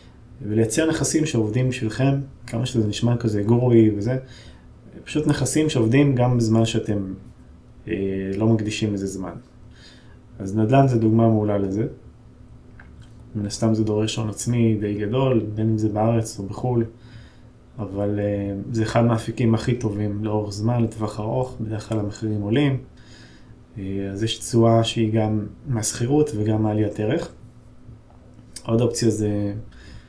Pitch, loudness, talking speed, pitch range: 110 Hz, -22 LUFS, 140 wpm, 105-120 Hz